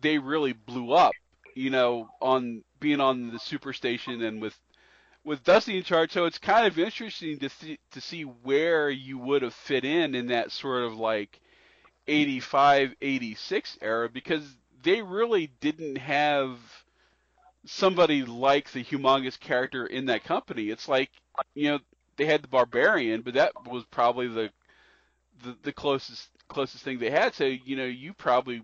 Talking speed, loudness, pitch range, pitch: 170 wpm, -27 LUFS, 125-150 Hz, 135 Hz